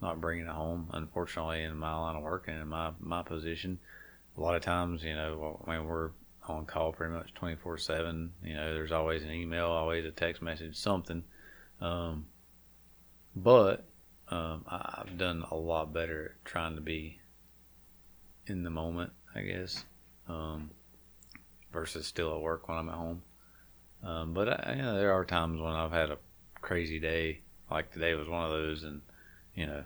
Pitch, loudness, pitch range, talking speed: 80 Hz, -35 LUFS, 75-85 Hz, 180 wpm